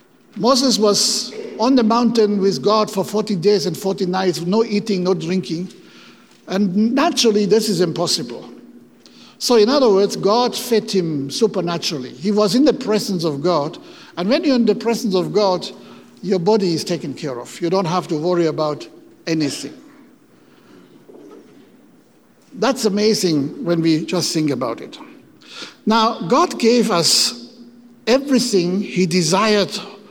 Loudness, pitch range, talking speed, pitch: -17 LUFS, 180-225 Hz, 145 wpm, 205 Hz